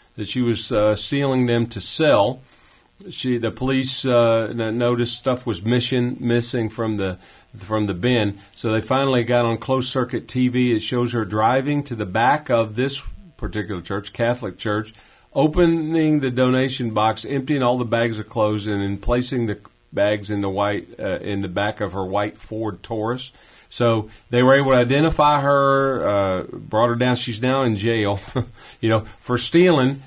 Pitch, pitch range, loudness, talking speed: 120 Hz, 105-130 Hz, -20 LUFS, 180 wpm